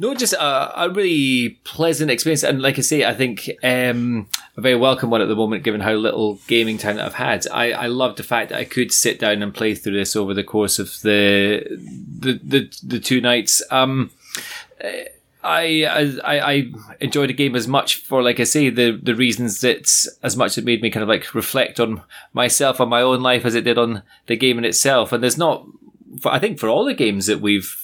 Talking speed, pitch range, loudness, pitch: 225 wpm, 110-135 Hz, -18 LUFS, 120 Hz